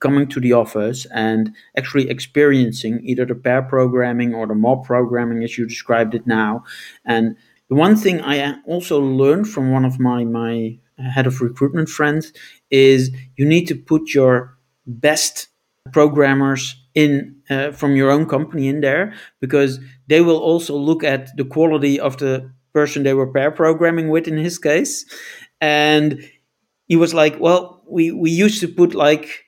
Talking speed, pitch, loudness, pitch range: 165 wpm, 140 Hz, -17 LUFS, 125-155 Hz